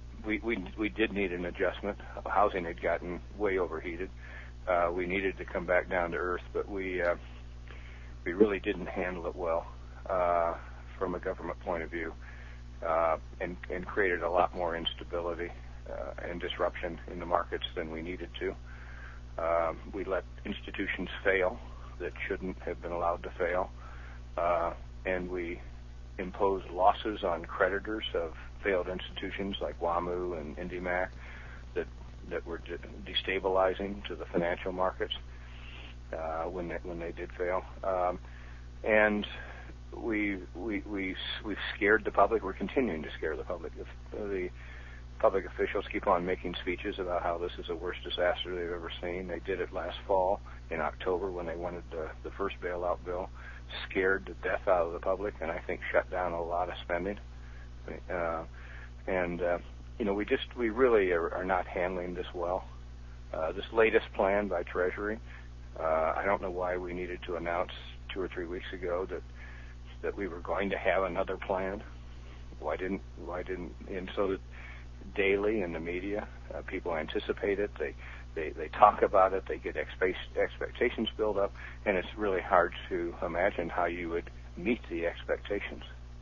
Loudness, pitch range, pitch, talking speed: -33 LUFS, 60-90 Hz, 80 Hz, 170 wpm